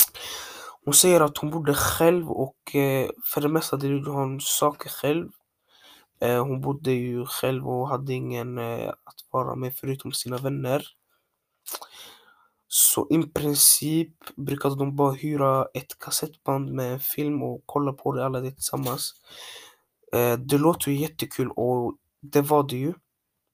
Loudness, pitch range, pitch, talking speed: -24 LUFS, 130-150 Hz, 140 Hz, 150 wpm